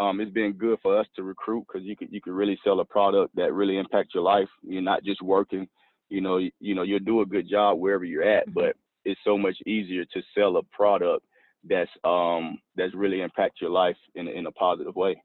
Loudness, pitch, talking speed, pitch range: -26 LUFS, 100 Hz, 235 wpm, 95-105 Hz